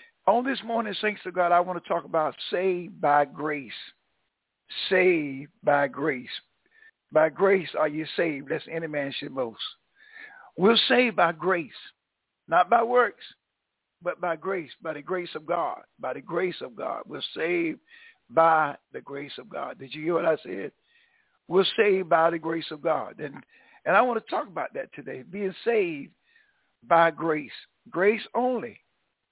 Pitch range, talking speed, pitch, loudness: 160-235 Hz, 170 wpm, 180 Hz, -26 LUFS